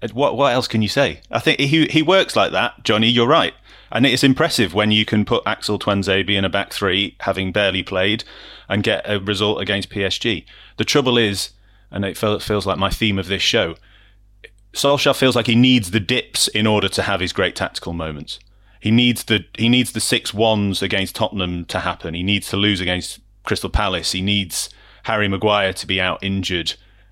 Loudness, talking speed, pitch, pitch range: -18 LUFS, 210 wpm, 105 Hz, 95-115 Hz